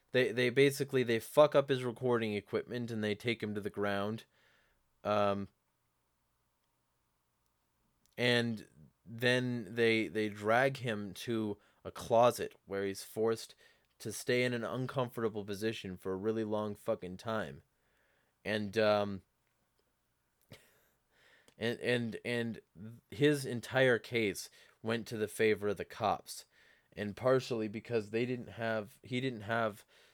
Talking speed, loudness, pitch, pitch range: 130 wpm, -34 LUFS, 110 Hz, 105-120 Hz